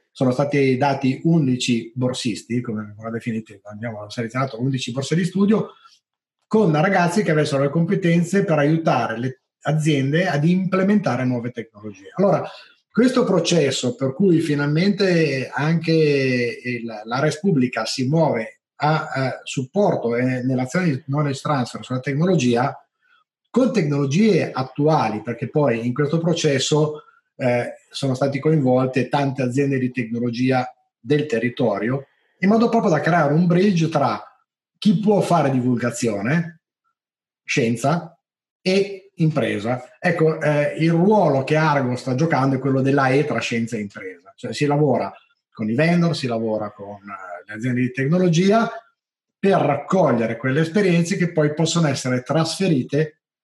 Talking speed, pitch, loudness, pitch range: 140 wpm, 145 Hz, -20 LUFS, 125-175 Hz